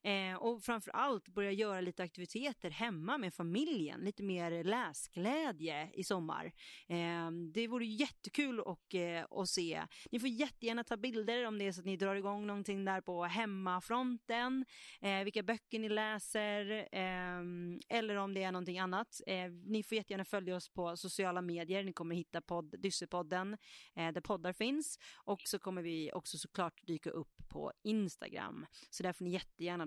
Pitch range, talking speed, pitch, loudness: 180-220 Hz, 155 wpm, 195 Hz, -40 LUFS